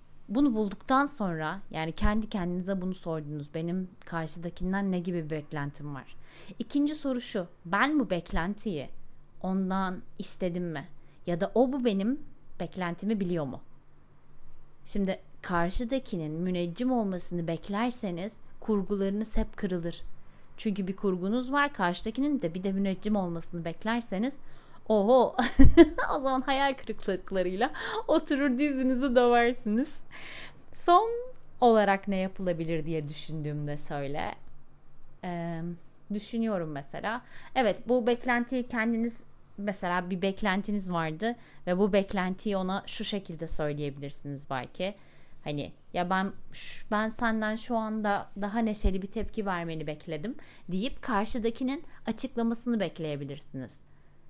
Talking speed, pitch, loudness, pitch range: 115 wpm, 195 Hz, -30 LUFS, 170-230 Hz